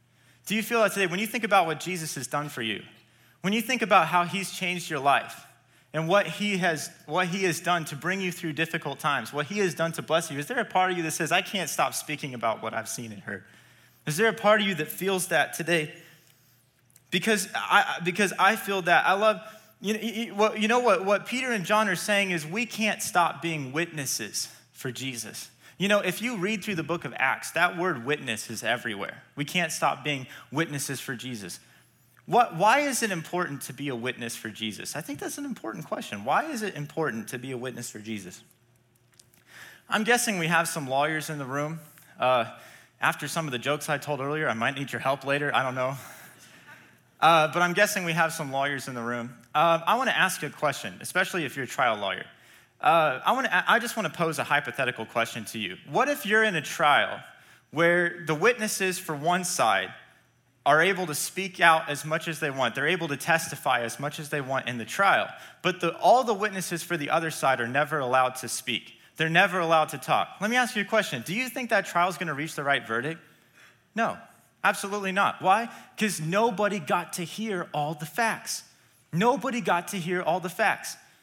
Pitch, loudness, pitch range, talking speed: 165 Hz, -26 LUFS, 140-195 Hz, 225 wpm